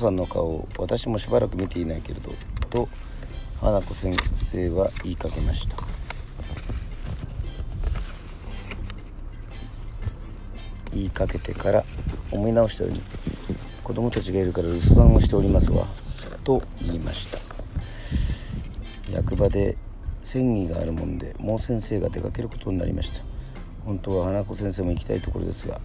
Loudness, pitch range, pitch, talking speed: -26 LUFS, 90-105 Hz, 95 Hz, 280 characters per minute